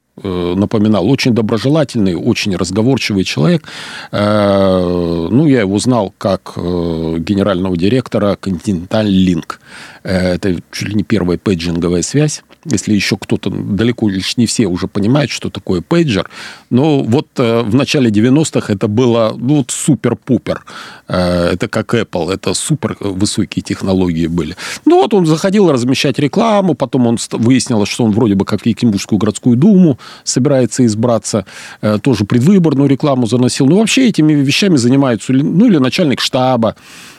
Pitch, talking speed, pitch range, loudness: 115 Hz, 135 wpm, 100-135 Hz, -13 LUFS